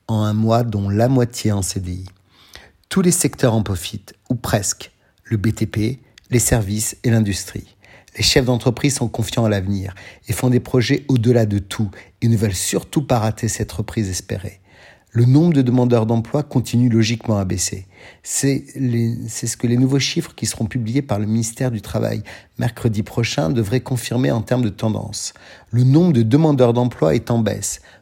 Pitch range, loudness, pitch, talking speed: 105-125 Hz, -19 LUFS, 115 Hz, 180 wpm